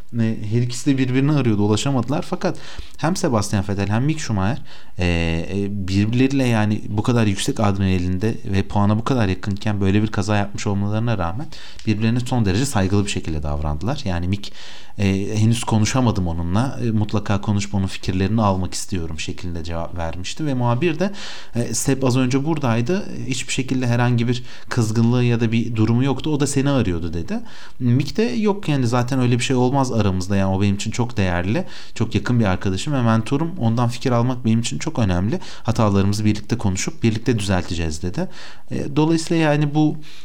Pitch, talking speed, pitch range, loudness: 115 Hz, 170 wpm, 100-130 Hz, -21 LUFS